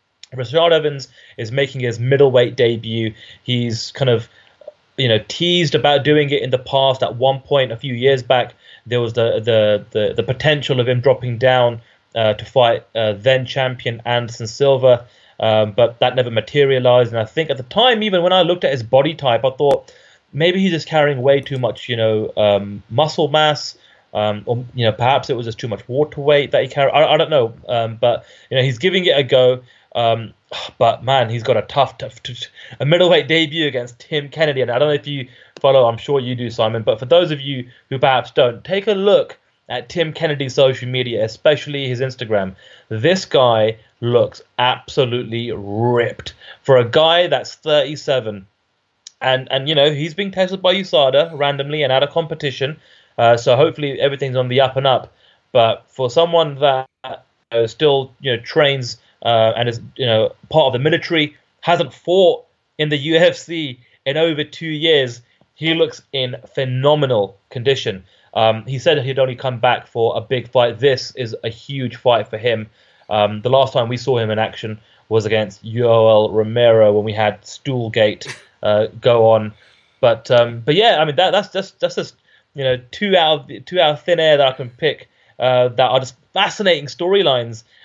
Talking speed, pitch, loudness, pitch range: 195 wpm, 130 Hz, -16 LUFS, 115-150 Hz